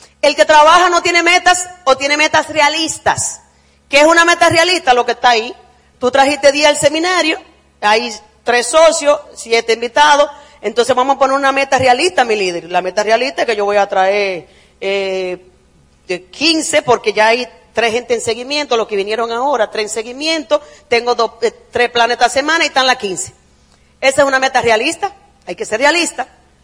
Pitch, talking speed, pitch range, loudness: 255 Hz, 185 wpm, 220-300 Hz, -13 LUFS